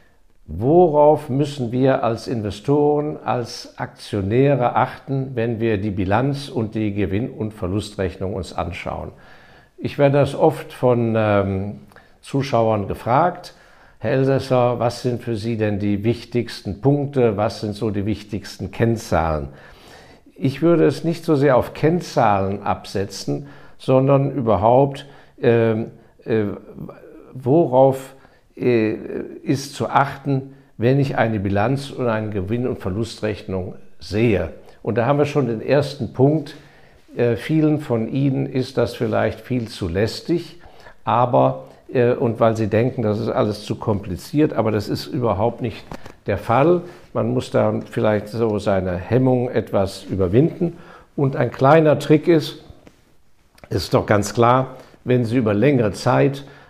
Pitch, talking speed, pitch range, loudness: 120 Hz, 135 wpm, 105-135 Hz, -20 LUFS